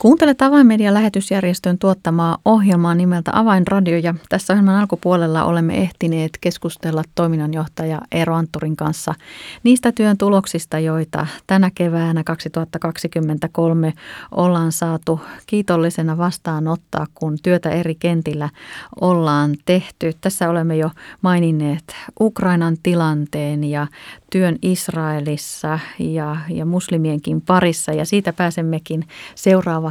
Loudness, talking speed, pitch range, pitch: -18 LUFS, 105 wpm, 160-185 Hz, 170 Hz